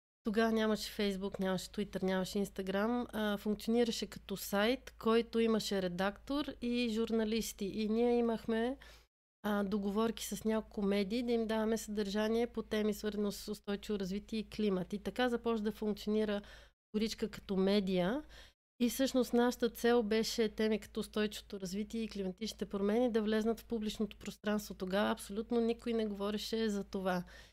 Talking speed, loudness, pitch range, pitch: 145 wpm, -36 LUFS, 205-230 Hz, 215 Hz